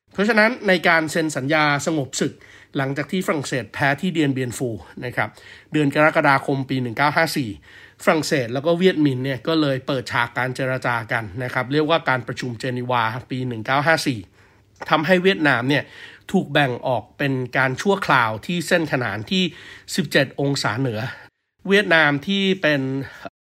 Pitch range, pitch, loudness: 130-160 Hz, 140 Hz, -20 LUFS